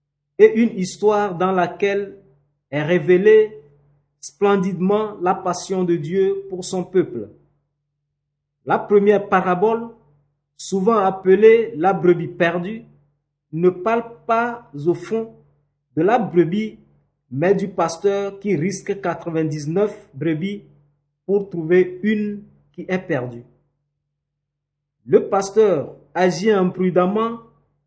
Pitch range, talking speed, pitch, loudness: 145-200 Hz, 105 wpm, 180 Hz, -19 LUFS